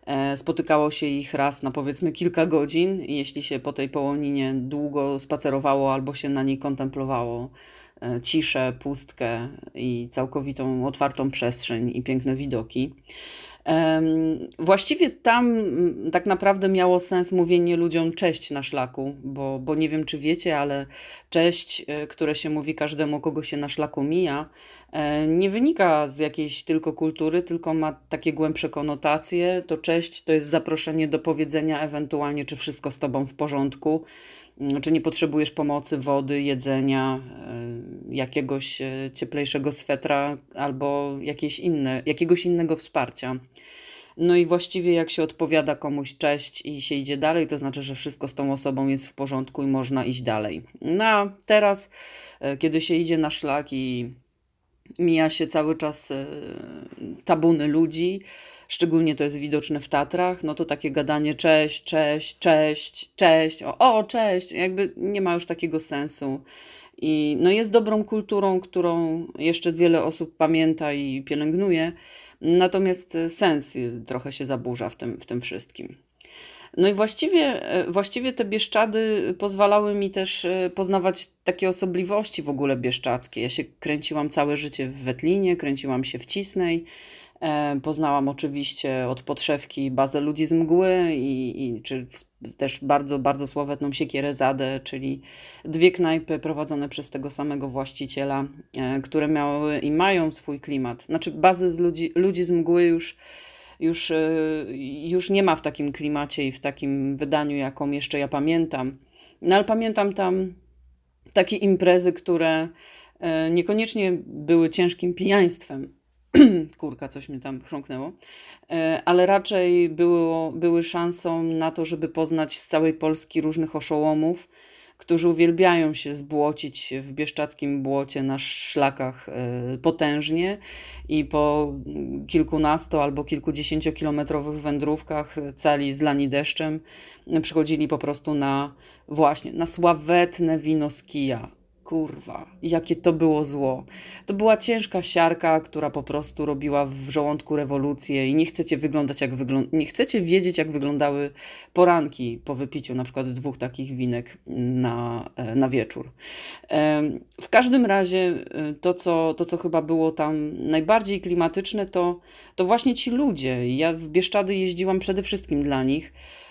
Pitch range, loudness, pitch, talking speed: 140-170 Hz, -24 LUFS, 155 Hz, 140 wpm